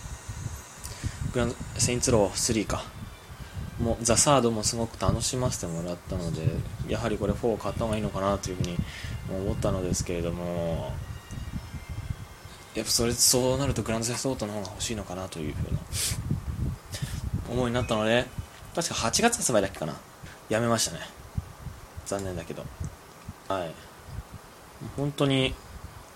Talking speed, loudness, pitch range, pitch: 305 characters per minute, -28 LUFS, 95-120 Hz, 110 Hz